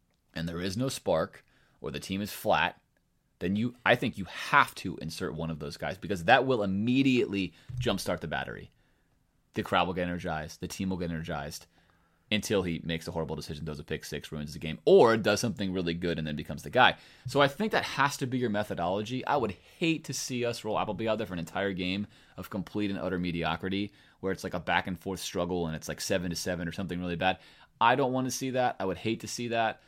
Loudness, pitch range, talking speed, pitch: -30 LUFS, 85-110 Hz, 245 wpm, 95 Hz